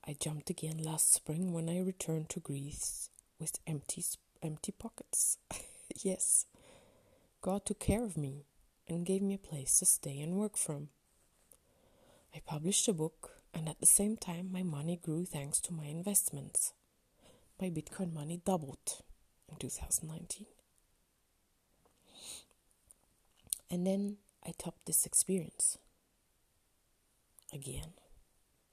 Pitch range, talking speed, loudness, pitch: 150-190 Hz, 125 wpm, -35 LUFS, 170 Hz